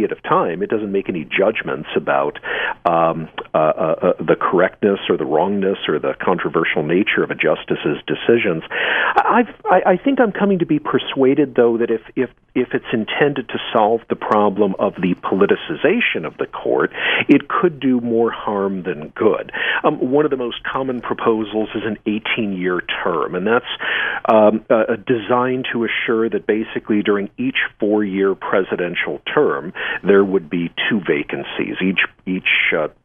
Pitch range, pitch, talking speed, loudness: 100-125 Hz, 110 Hz, 175 wpm, -18 LUFS